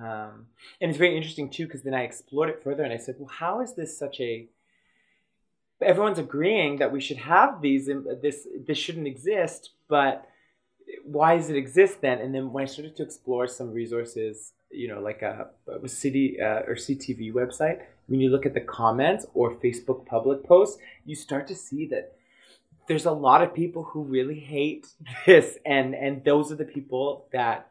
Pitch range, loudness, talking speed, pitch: 130-155 Hz, -25 LUFS, 190 wpm, 140 Hz